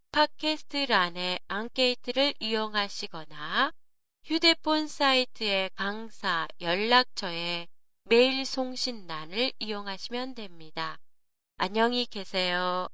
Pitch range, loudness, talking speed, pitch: 185-255 Hz, -28 LUFS, 230 characters per minute, 225 Hz